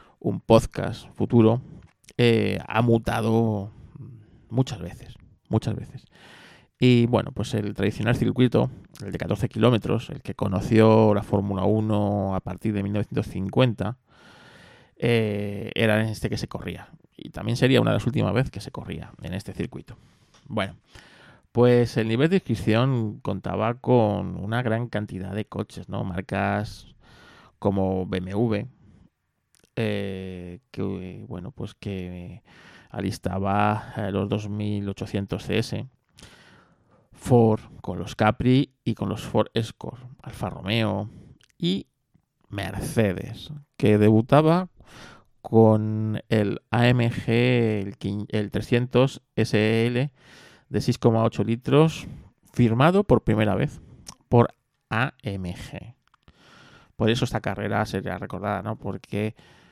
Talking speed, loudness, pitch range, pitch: 115 wpm, -24 LUFS, 100-120 Hz, 110 Hz